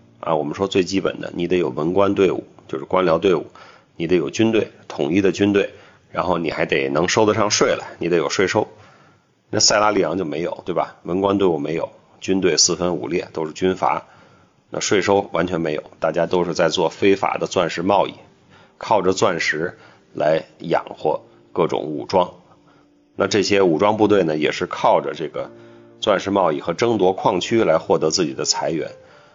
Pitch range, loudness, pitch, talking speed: 85-100 Hz, -19 LUFS, 95 Hz, 275 characters per minute